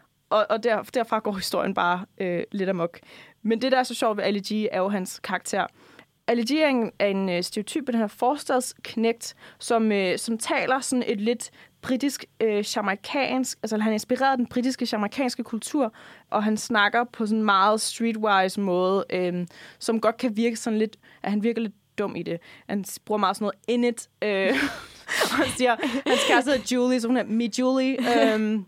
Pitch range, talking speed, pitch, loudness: 200-245 Hz, 190 wpm, 225 Hz, -25 LUFS